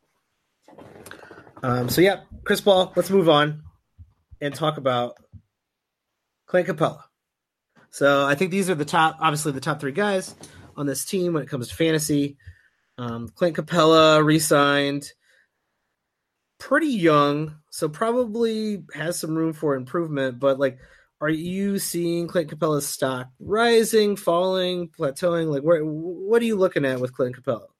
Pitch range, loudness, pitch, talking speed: 140-180 Hz, -22 LUFS, 160 Hz, 145 wpm